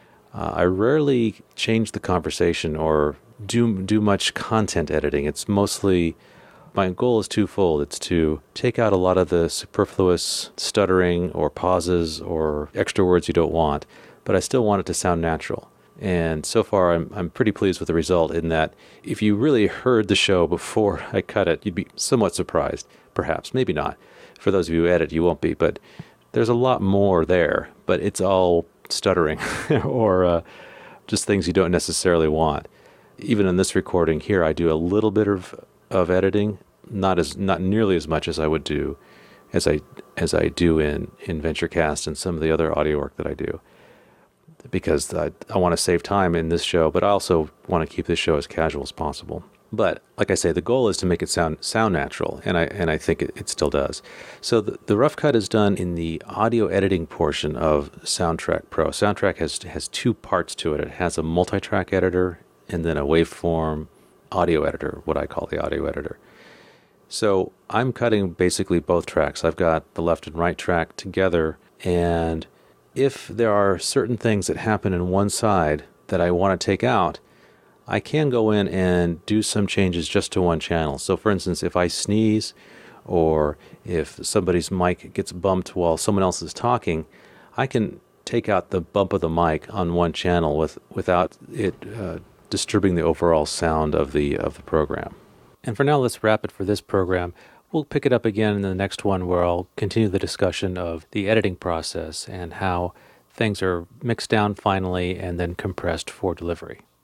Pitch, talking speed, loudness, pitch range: 90 Hz, 195 wpm, -22 LUFS, 85-100 Hz